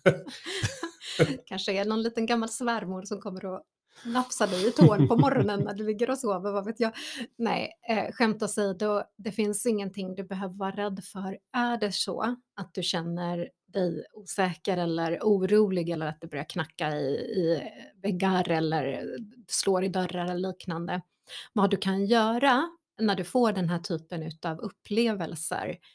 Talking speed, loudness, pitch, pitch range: 165 wpm, -28 LUFS, 200 Hz, 180-225 Hz